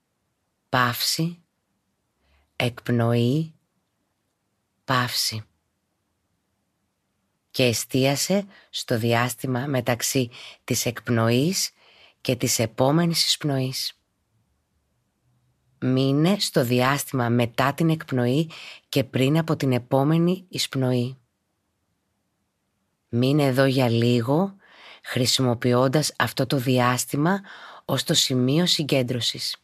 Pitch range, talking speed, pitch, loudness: 115-140 Hz, 75 wpm, 125 Hz, -23 LUFS